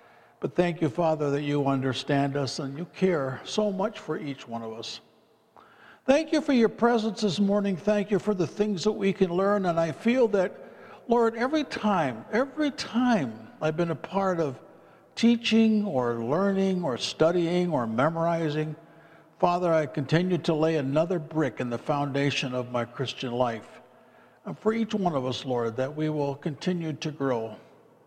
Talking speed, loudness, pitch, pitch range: 175 wpm, -27 LUFS, 165 Hz, 140-205 Hz